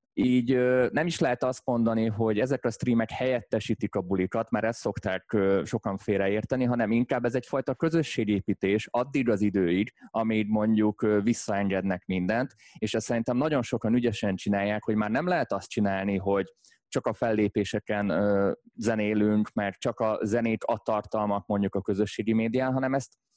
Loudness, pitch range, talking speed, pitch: -27 LUFS, 105-120 Hz, 165 wpm, 110 Hz